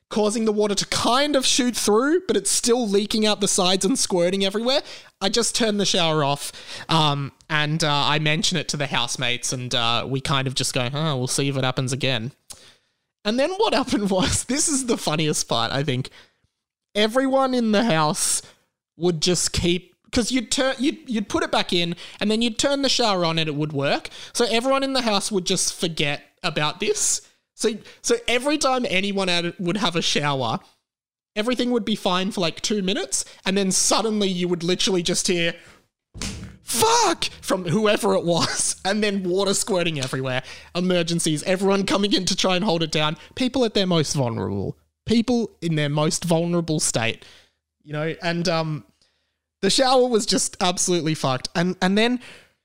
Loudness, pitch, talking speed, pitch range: -21 LUFS, 185 Hz, 190 wpm, 155-220 Hz